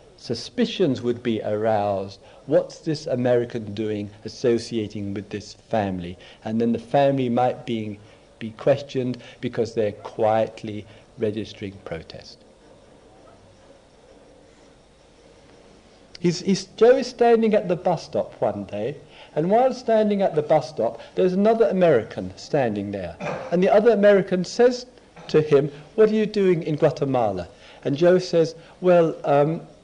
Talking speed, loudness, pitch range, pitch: 135 wpm, -22 LUFS, 110-180 Hz, 140 Hz